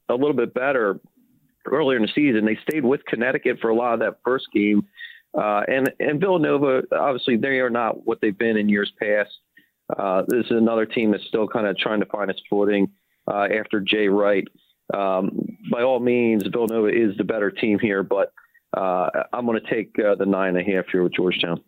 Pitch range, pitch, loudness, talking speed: 100-130 Hz, 110 Hz, -22 LUFS, 210 wpm